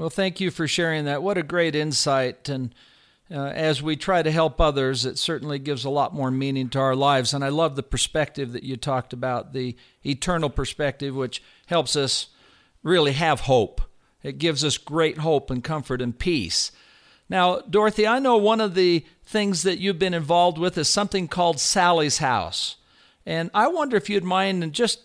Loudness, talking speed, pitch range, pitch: -23 LUFS, 195 wpm, 135-180 Hz, 155 Hz